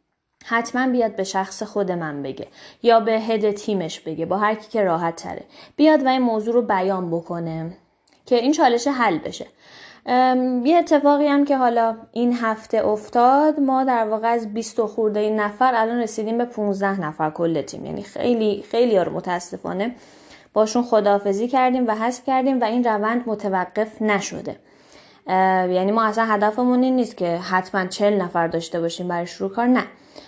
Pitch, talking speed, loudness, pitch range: 220 Hz, 170 wpm, -20 LUFS, 190-245 Hz